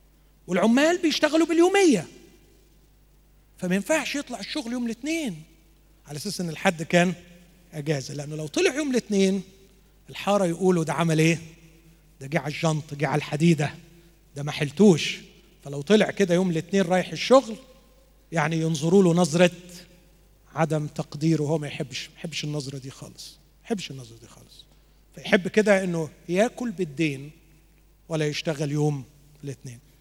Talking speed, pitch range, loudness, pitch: 140 wpm, 155-195 Hz, -24 LUFS, 170 Hz